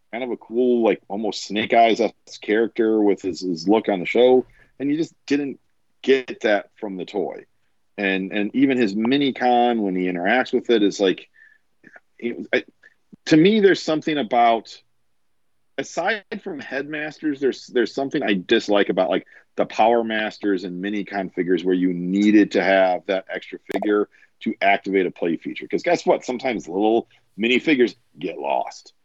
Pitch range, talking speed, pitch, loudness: 100-135 Hz, 170 wpm, 110 Hz, -21 LUFS